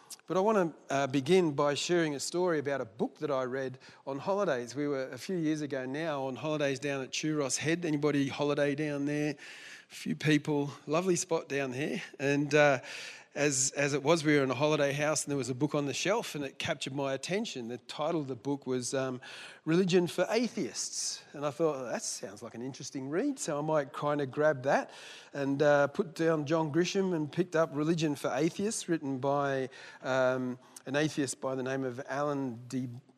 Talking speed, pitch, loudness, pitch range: 210 wpm, 145 Hz, -31 LUFS, 135-160 Hz